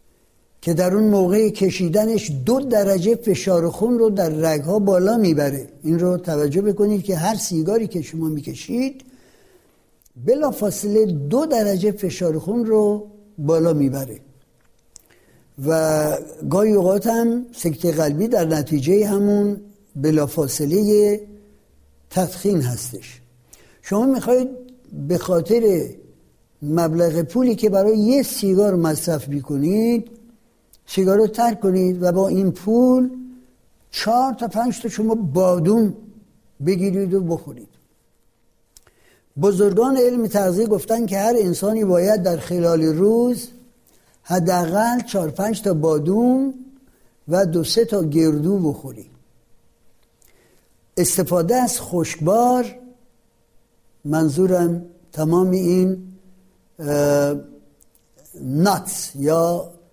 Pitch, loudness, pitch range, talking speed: 190 Hz, -19 LUFS, 165-220 Hz, 105 wpm